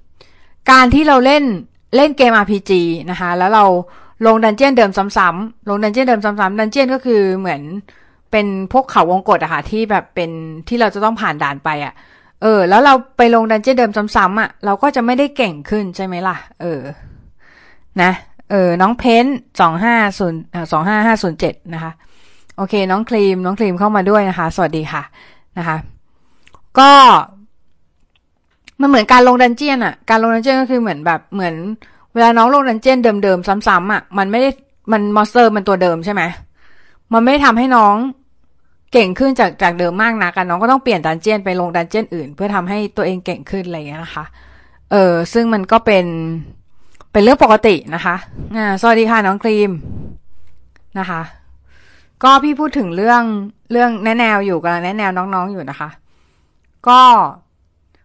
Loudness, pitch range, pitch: -13 LUFS, 175-230 Hz, 205 Hz